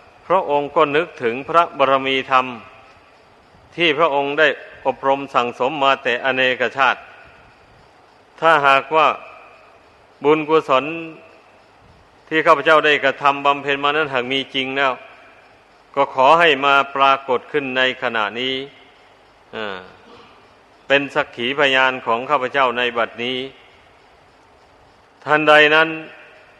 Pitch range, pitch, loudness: 130-150 Hz, 140 Hz, -17 LUFS